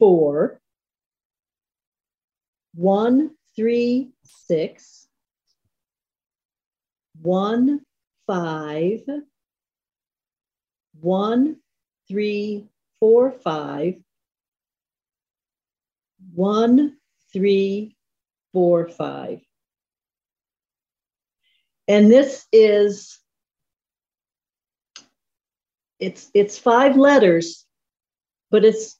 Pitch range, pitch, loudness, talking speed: 185-255 Hz, 210 Hz, -19 LUFS, 50 wpm